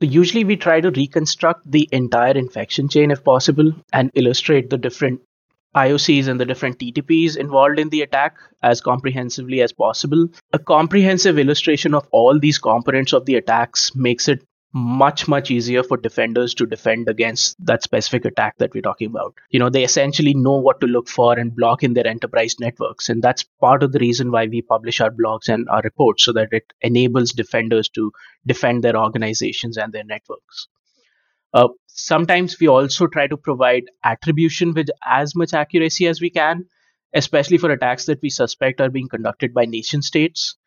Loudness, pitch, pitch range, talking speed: -17 LUFS, 135 Hz, 120-155 Hz, 180 wpm